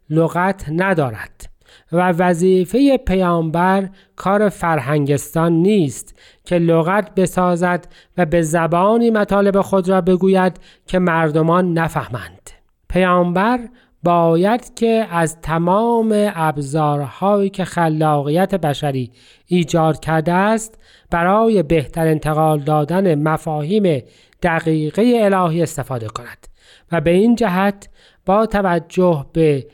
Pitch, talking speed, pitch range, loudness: 175 Hz, 100 wpm, 160-195 Hz, -16 LUFS